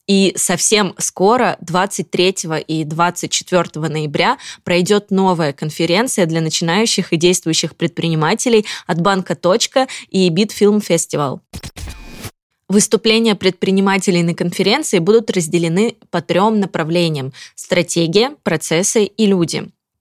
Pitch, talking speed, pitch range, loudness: 185 Hz, 100 wpm, 170-205 Hz, -15 LUFS